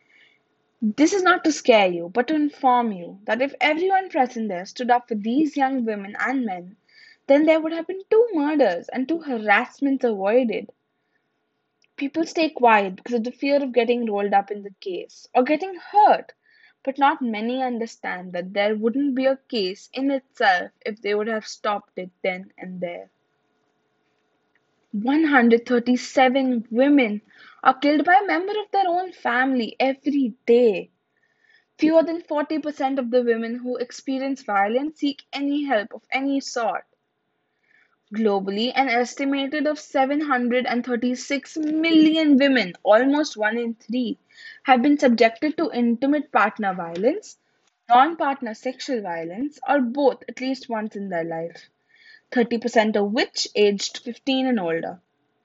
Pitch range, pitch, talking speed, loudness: 225-300 Hz, 255 Hz, 145 wpm, -22 LUFS